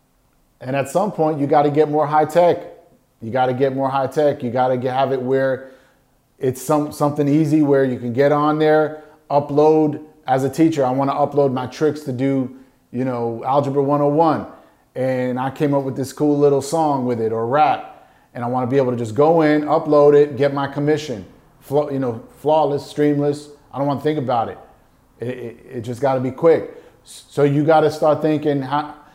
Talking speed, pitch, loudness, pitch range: 210 wpm, 145 Hz, -18 LUFS, 130-150 Hz